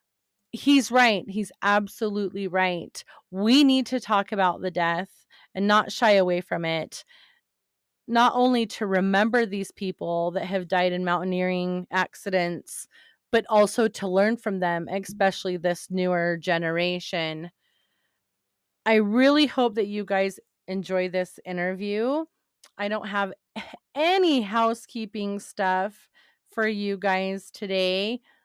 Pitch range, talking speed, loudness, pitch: 185-225 Hz, 125 wpm, -24 LUFS, 200 Hz